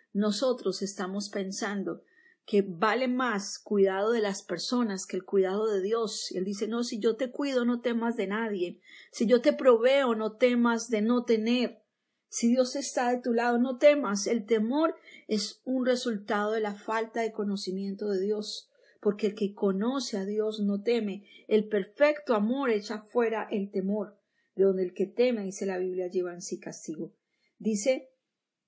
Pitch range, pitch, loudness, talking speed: 200-245 Hz, 215 Hz, -29 LUFS, 175 wpm